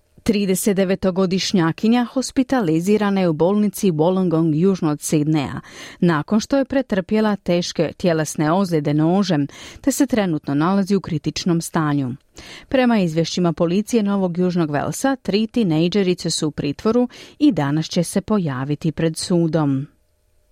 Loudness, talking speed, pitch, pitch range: -19 LUFS, 125 wpm, 175 Hz, 155-205 Hz